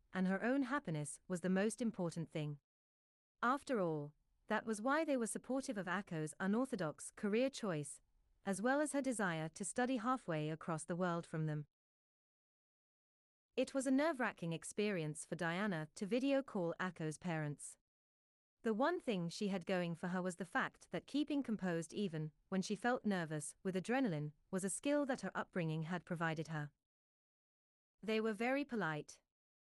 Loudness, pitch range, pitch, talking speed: -41 LUFS, 160-240 Hz, 190 Hz, 165 wpm